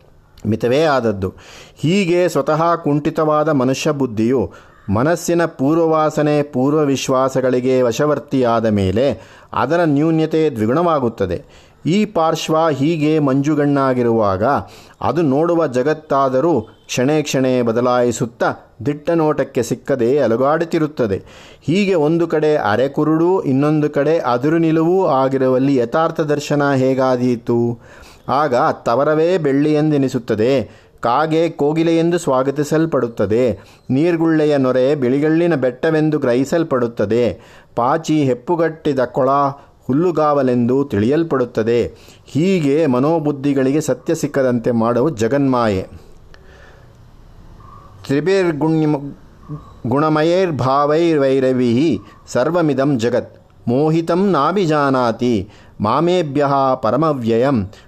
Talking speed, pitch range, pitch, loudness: 75 wpm, 120-155 Hz, 140 Hz, -16 LUFS